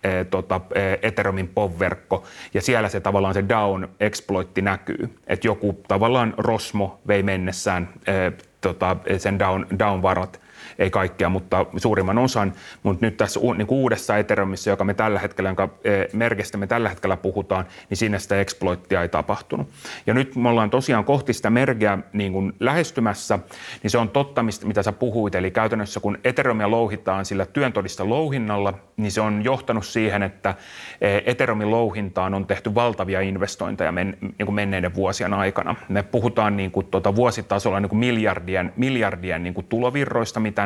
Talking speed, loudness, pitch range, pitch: 150 wpm, -22 LUFS, 95-115 Hz, 100 Hz